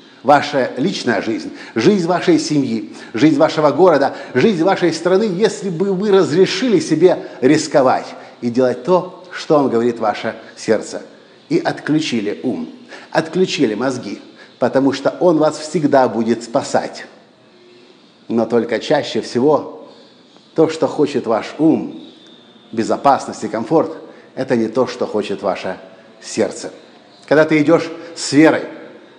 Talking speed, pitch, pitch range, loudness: 125 wpm, 155 Hz, 120-180 Hz, -16 LUFS